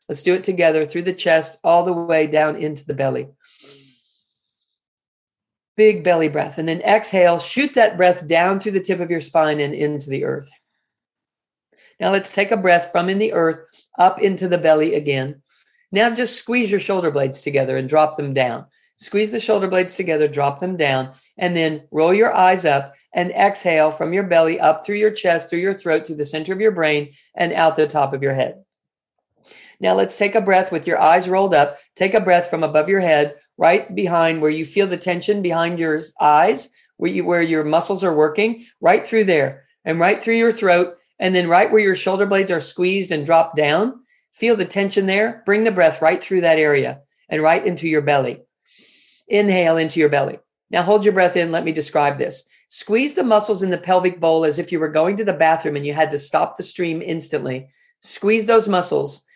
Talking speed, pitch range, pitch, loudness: 210 wpm, 155-195 Hz, 170 Hz, -18 LUFS